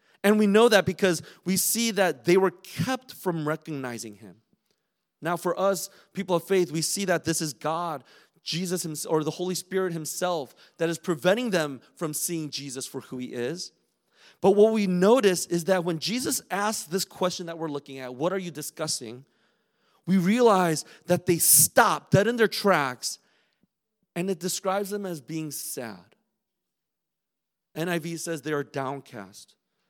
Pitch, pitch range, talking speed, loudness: 175 Hz, 155-190 Hz, 170 wpm, -25 LUFS